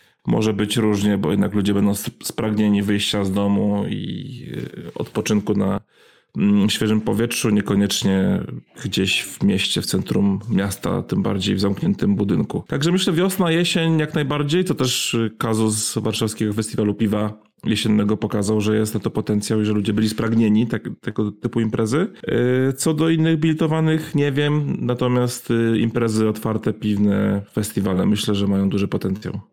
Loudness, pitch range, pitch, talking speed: -20 LUFS, 105-125 Hz, 110 Hz, 145 wpm